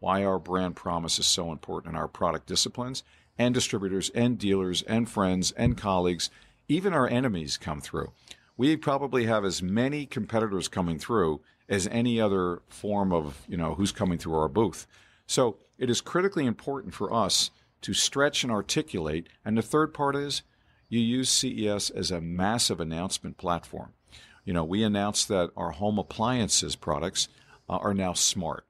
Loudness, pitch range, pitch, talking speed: -28 LUFS, 90-120 Hz, 105 Hz, 165 wpm